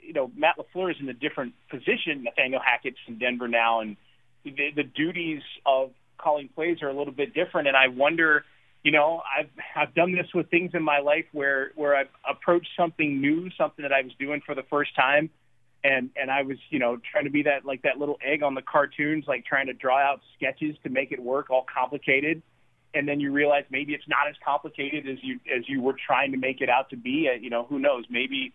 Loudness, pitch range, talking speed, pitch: -25 LUFS, 135-150 Hz, 230 wpm, 145 Hz